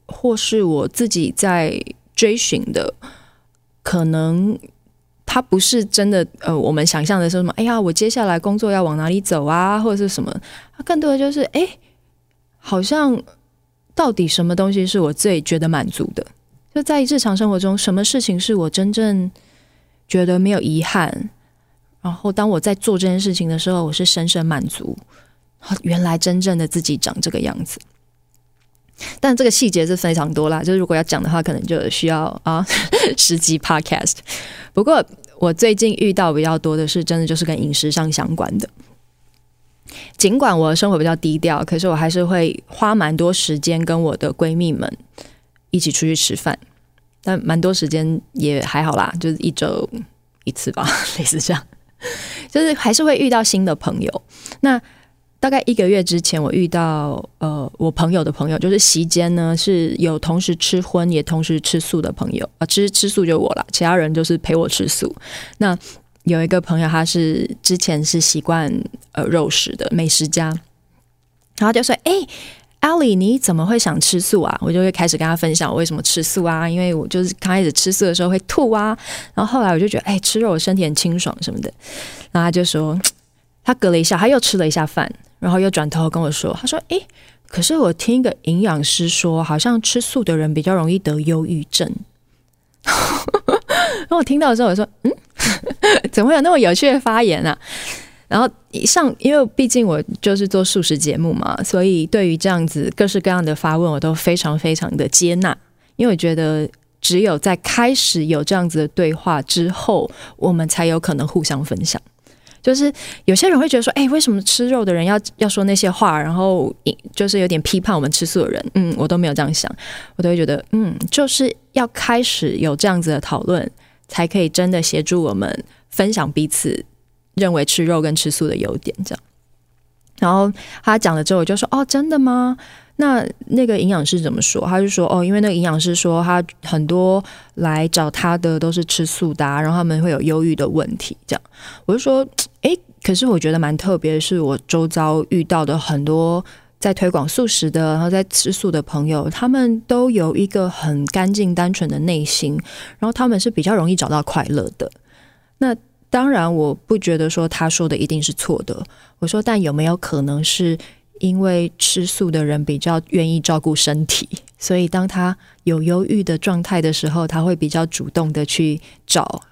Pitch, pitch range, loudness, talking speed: 175 Hz, 160-205 Hz, -17 LUFS, 285 characters per minute